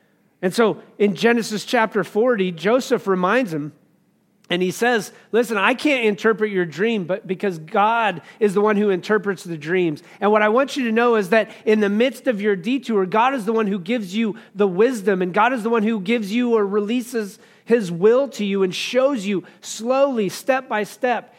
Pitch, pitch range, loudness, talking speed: 215 Hz, 200-235 Hz, -20 LUFS, 205 wpm